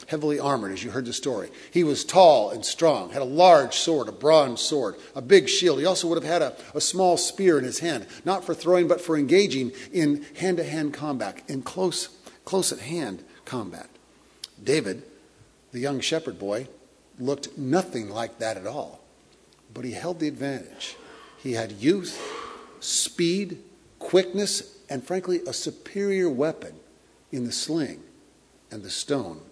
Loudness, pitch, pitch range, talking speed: -24 LUFS, 160 Hz, 135-185 Hz, 165 wpm